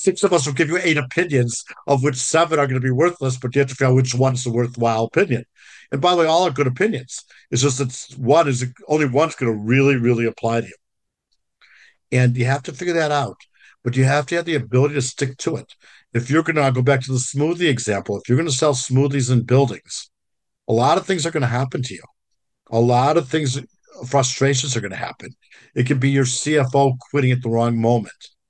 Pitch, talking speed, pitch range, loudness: 135 Hz, 240 wpm, 125-150 Hz, -19 LUFS